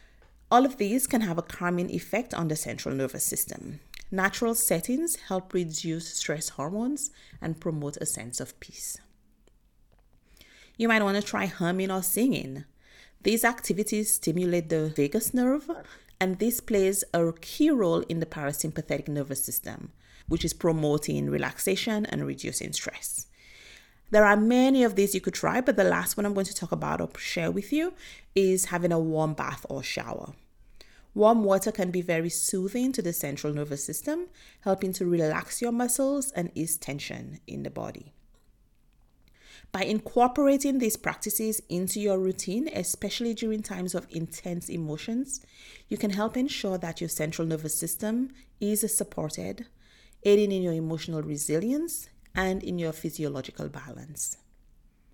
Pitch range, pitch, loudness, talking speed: 165-225 Hz, 190 Hz, -28 LUFS, 155 wpm